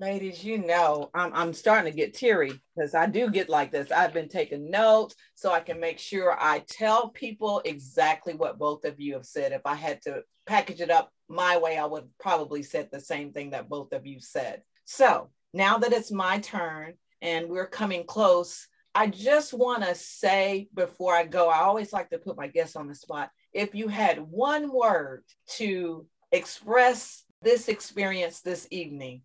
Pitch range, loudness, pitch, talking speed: 160-220 Hz, -27 LUFS, 180 Hz, 195 wpm